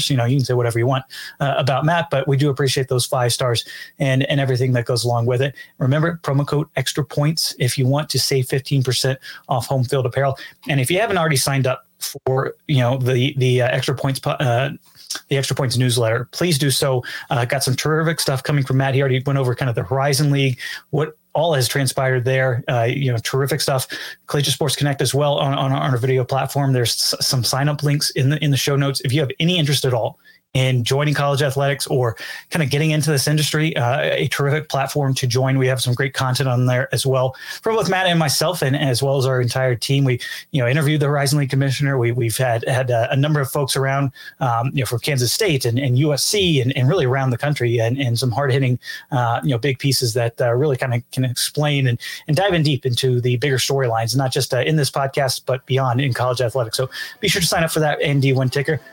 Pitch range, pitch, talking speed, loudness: 130-145 Hz, 135 Hz, 240 wpm, -19 LUFS